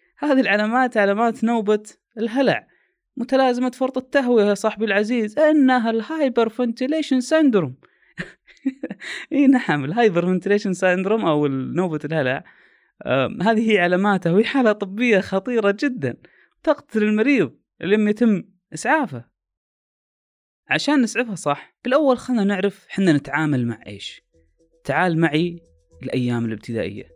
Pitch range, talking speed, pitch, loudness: 165-255 Hz, 115 wpm, 210 Hz, -20 LUFS